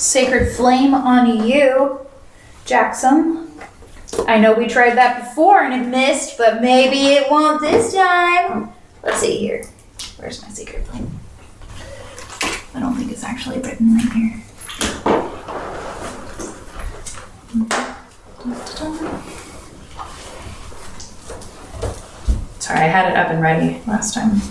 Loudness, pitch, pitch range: -16 LUFS, 255 Hz, 230-280 Hz